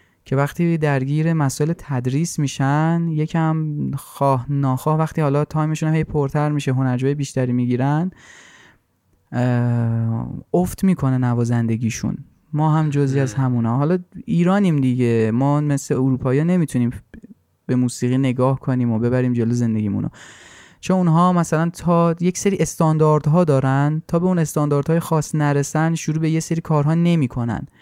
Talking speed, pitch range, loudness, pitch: 135 wpm, 125-160 Hz, -19 LUFS, 145 Hz